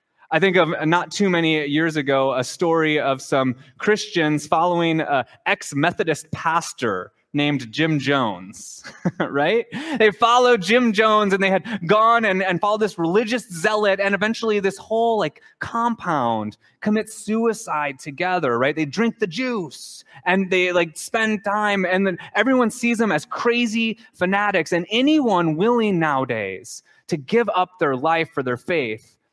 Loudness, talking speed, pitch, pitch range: -20 LUFS, 150 wpm, 185 Hz, 155-220 Hz